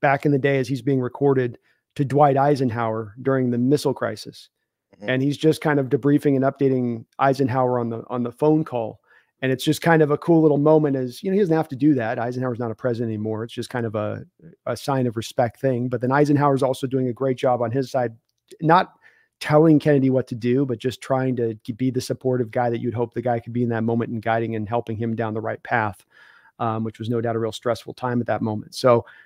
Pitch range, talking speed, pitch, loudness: 115-140 Hz, 250 wpm, 125 Hz, -22 LUFS